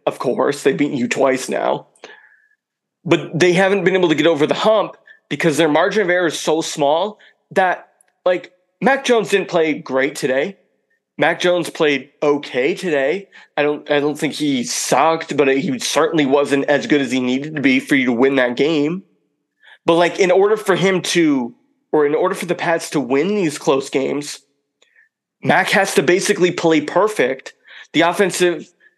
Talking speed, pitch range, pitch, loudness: 180 wpm, 145-190 Hz, 165 Hz, -17 LUFS